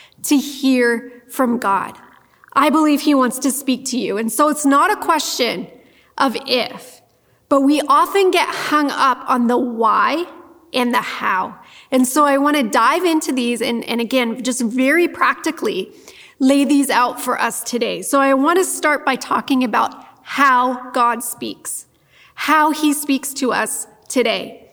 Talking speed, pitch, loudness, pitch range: 165 wpm, 275 Hz, -17 LUFS, 245-305 Hz